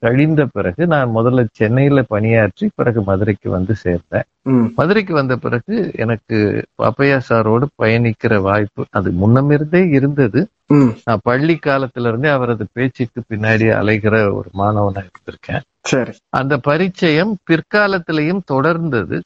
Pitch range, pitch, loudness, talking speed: 110-145 Hz, 120 Hz, -15 LUFS, 110 wpm